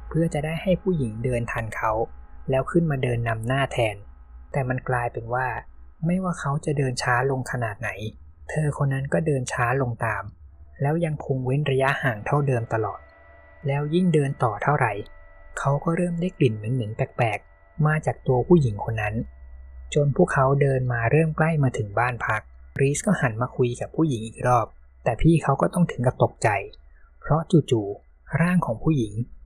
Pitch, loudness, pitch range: 130 Hz, -24 LUFS, 110-145 Hz